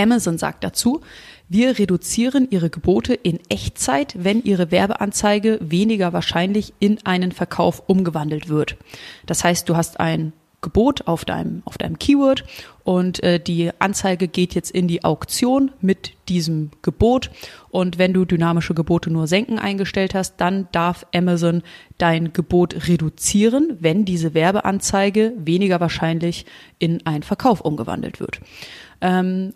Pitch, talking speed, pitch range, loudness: 180 Hz, 140 wpm, 170-205 Hz, -19 LUFS